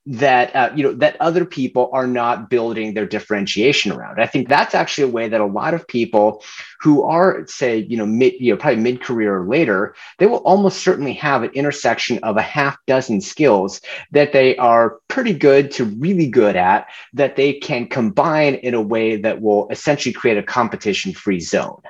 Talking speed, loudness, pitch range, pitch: 195 wpm, -17 LUFS, 110-145 Hz, 125 Hz